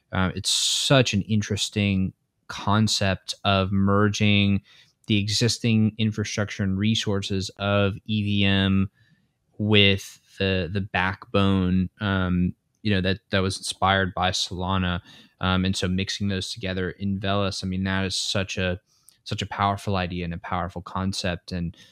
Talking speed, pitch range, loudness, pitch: 140 wpm, 95-105 Hz, -24 LUFS, 100 Hz